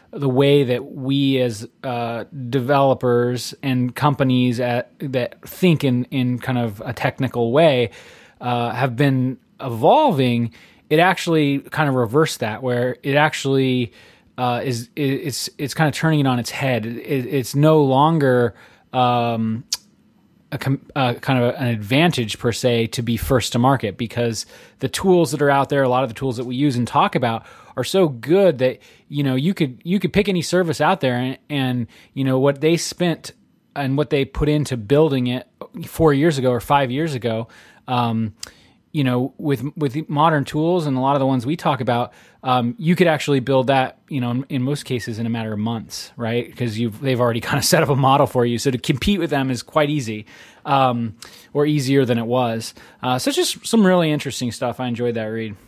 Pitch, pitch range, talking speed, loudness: 130 Hz, 120-150 Hz, 200 wpm, -20 LUFS